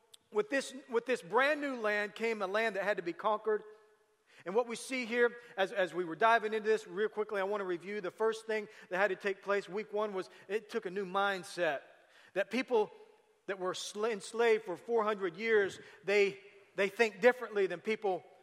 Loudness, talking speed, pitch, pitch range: -34 LUFS, 205 wpm, 215 Hz, 195-230 Hz